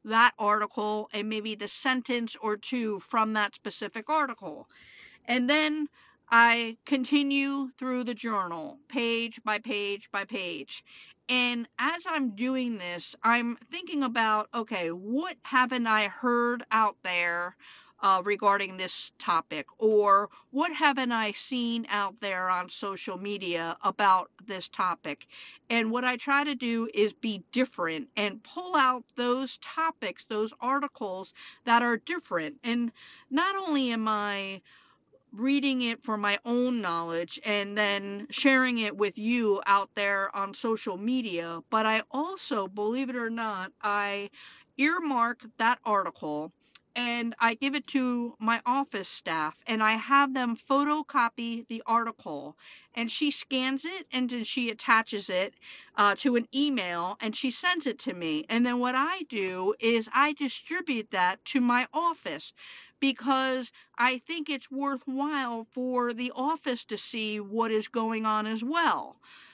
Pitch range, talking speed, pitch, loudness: 210-265 Hz, 145 wpm, 235 Hz, -28 LUFS